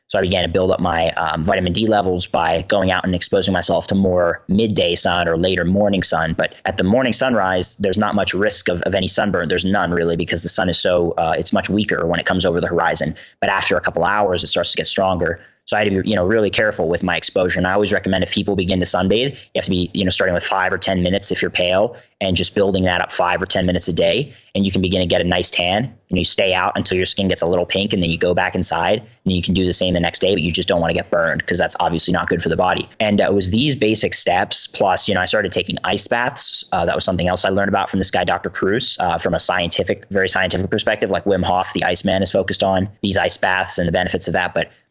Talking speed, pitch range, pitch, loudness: 290 wpm, 90-100 Hz, 95 Hz, -17 LUFS